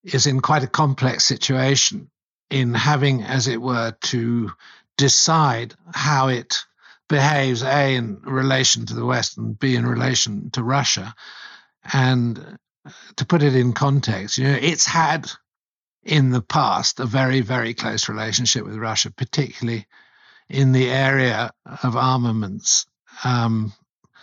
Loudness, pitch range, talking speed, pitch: -19 LUFS, 115-140 Hz, 135 wpm, 130 Hz